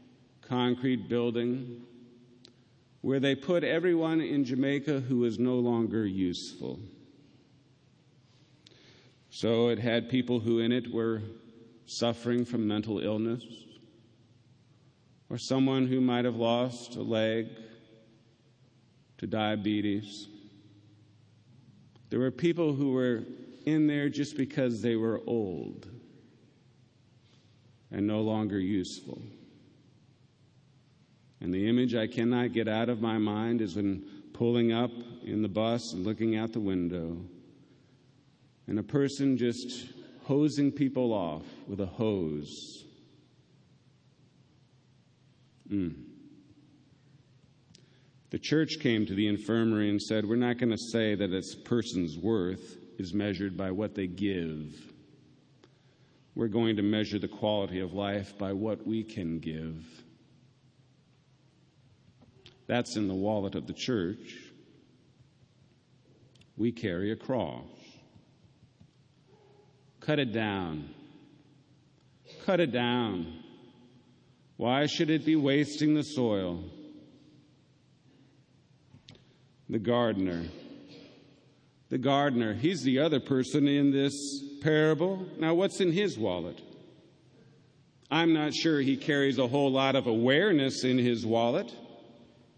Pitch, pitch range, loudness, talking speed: 125 Hz, 110-135 Hz, -30 LUFS, 110 wpm